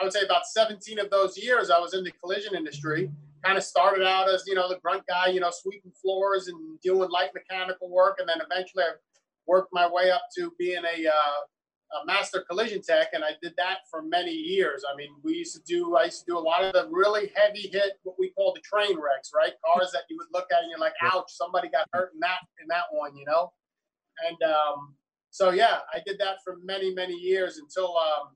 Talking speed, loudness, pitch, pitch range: 240 wpm, -26 LUFS, 185 Hz, 175-215 Hz